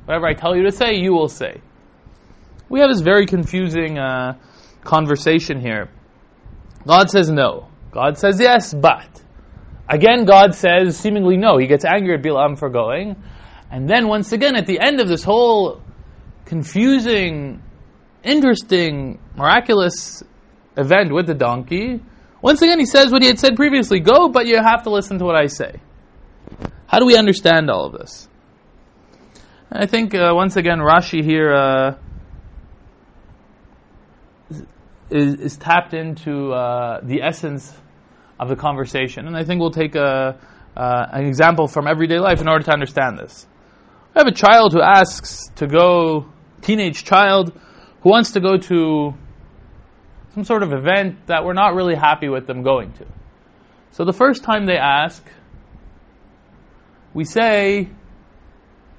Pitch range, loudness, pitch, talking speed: 140-200 Hz, -15 LUFS, 165 Hz, 155 wpm